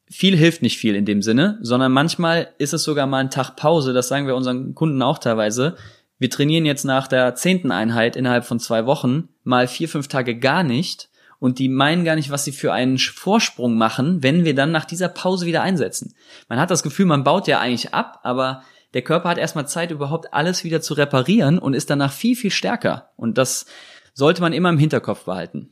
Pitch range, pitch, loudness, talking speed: 125-165 Hz, 140 Hz, -19 LUFS, 215 wpm